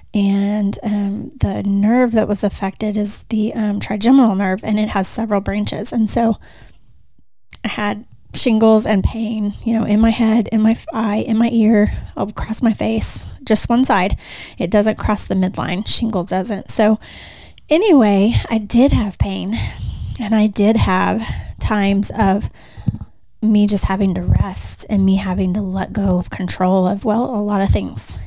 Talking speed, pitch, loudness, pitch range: 170 wpm, 210 Hz, -17 LUFS, 195-220 Hz